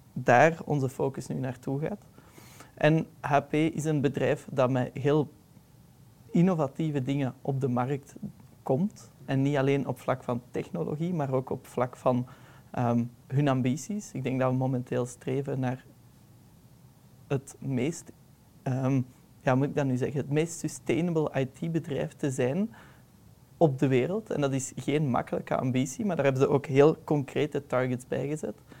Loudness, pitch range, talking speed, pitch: -29 LUFS, 130-150 Hz, 160 wpm, 140 Hz